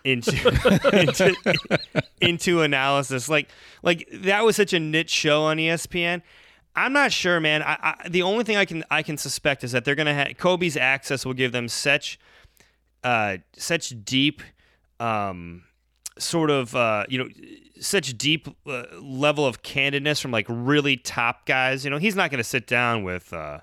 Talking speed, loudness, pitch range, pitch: 175 wpm, -22 LUFS, 130-170 Hz, 145 Hz